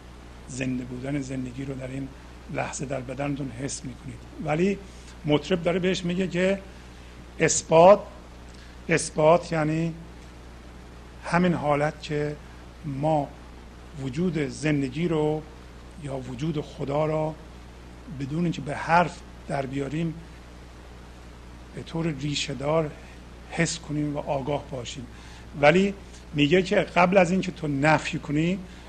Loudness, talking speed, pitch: -25 LUFS, 110 wpm, 145 Hz